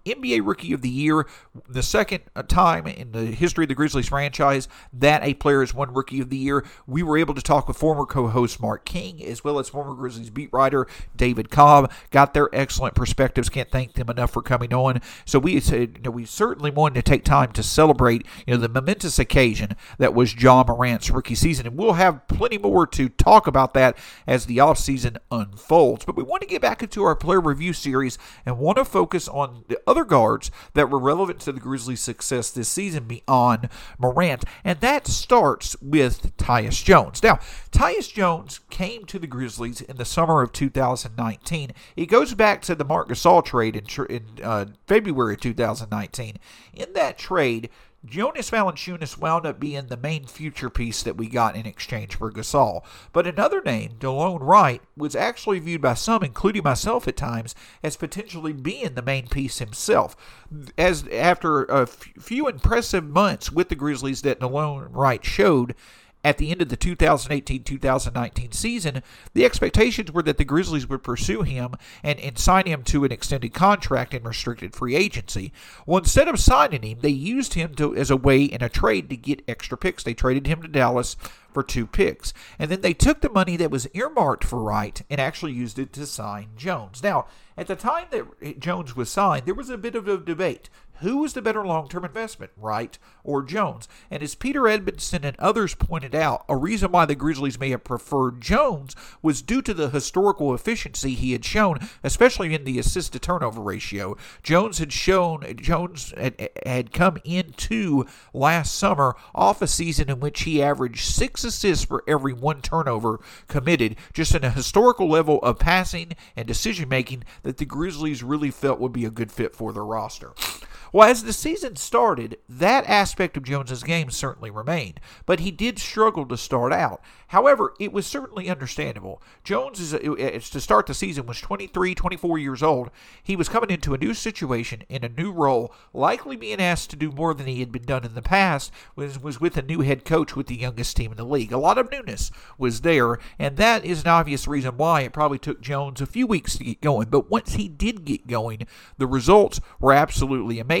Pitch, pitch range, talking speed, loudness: 145 Hz, 125-175 Hz, 195 wpm, -22 LUFS